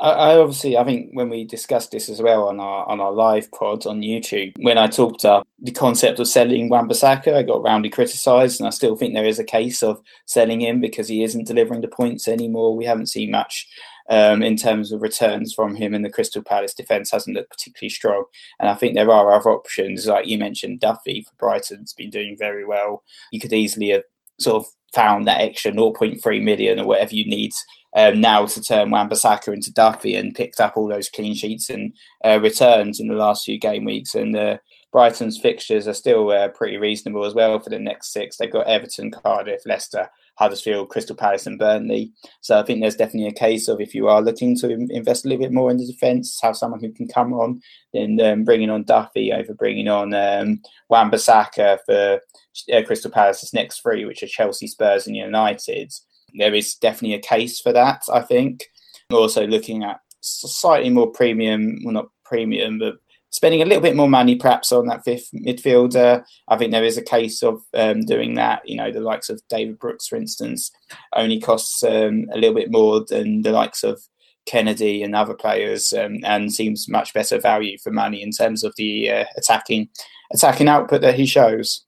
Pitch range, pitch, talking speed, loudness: 110-155 Hz, 115 Hz, 205 wpm, -18 LUFS